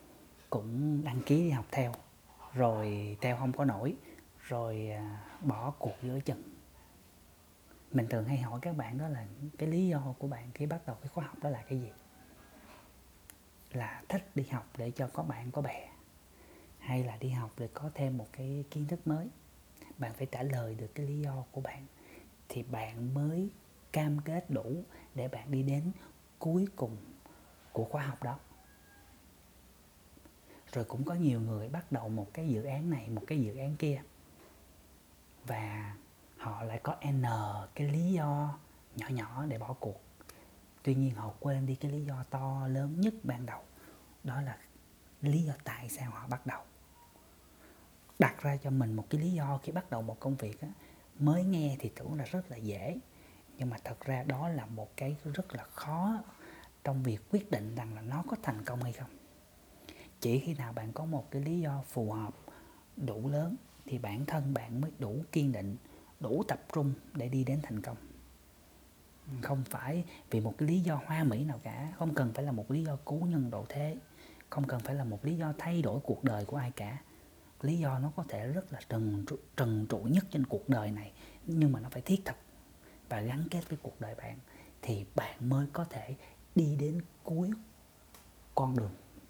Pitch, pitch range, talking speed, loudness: 135 Hz, 110-145 Hz, 195 wpm, -36 LUFS